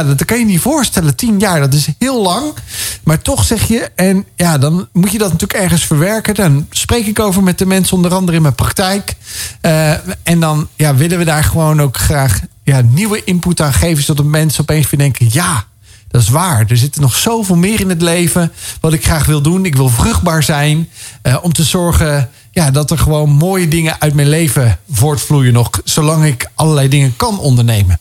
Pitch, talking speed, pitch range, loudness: 155 Hz, 215 wpm, 135-175 Hz, -12 LUFS